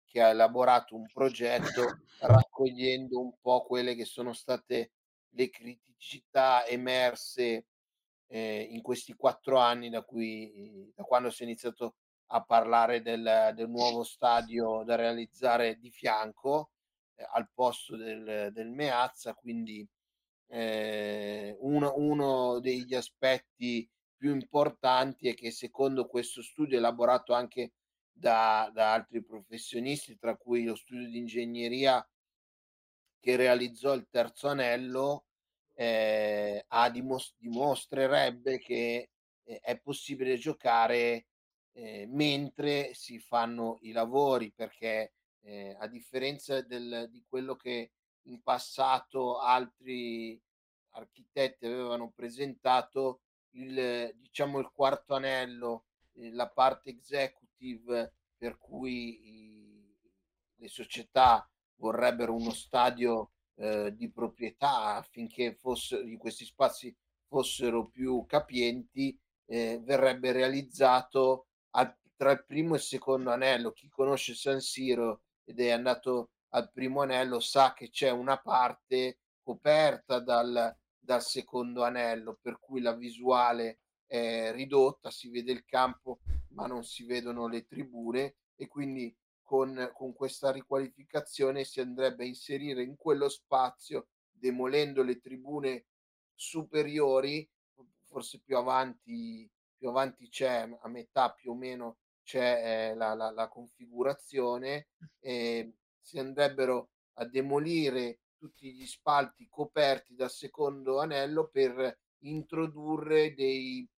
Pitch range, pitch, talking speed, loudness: 115-135 Hz, 125 Hz, 120 wpm, -31 LUFS